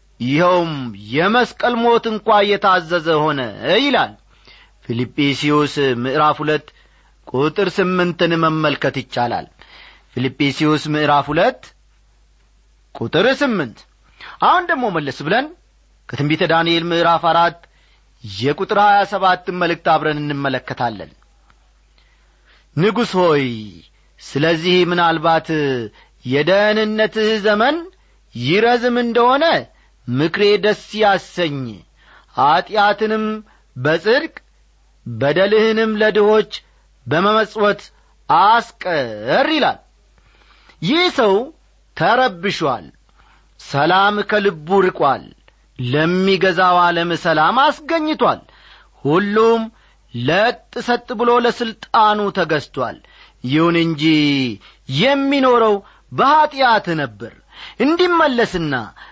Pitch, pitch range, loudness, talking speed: 175 Hz, 145-215 Hz, -16 LUFS, 75 wpm